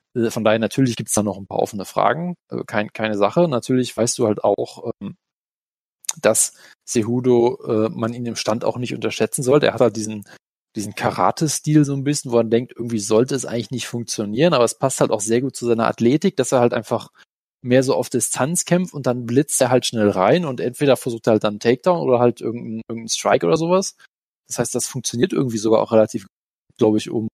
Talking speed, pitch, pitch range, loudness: 215 wpm, 120 Hz, 110-130 Hz, -19 LUFS